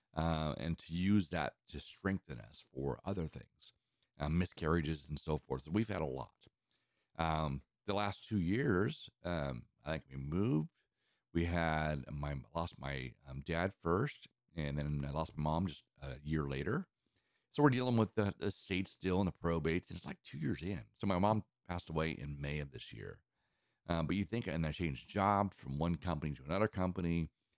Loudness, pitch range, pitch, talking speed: -38 LUFS, 75-95 Hz, 85 Hz, 195 wpm